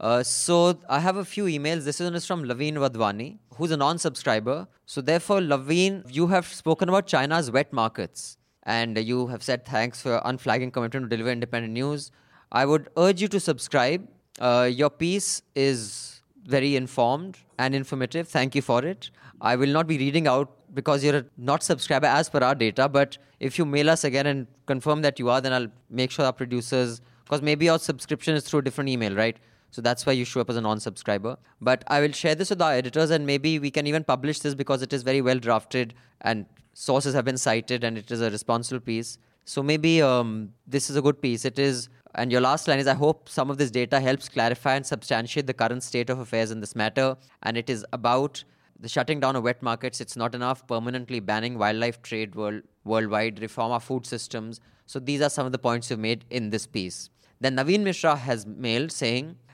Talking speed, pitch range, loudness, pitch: 215 wpm, 120-145 Hz, -25 LUFS, 130 Hz